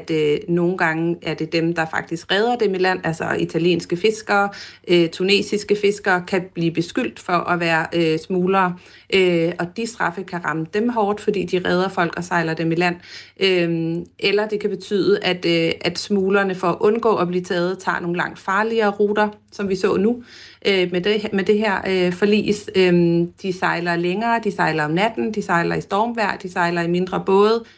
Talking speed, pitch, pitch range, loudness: 200 wpm, 185 Hz, 170-205 Hz, -20 LUFS